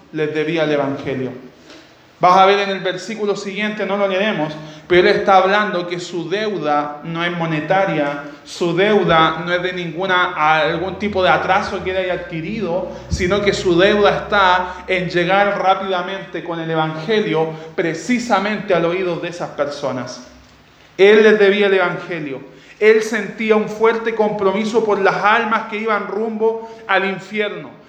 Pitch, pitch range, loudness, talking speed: 185 Hz, 165-200 Hz, -17 LUFS, 155 wpm